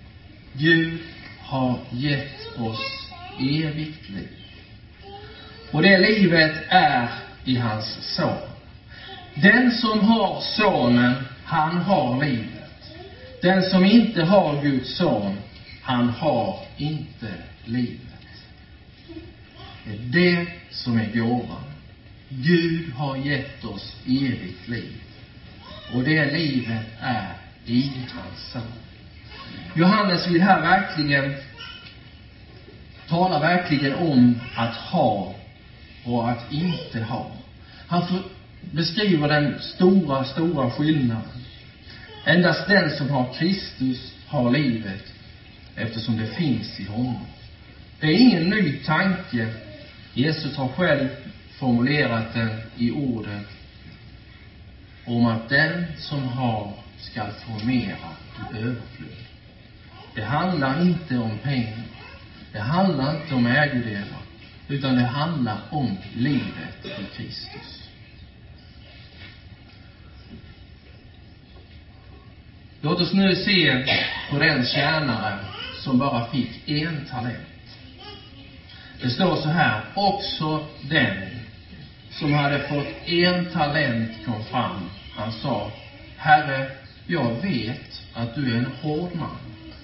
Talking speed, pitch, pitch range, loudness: 105 wpm, 125 Hz, 110-150 Hz, -22 LUFS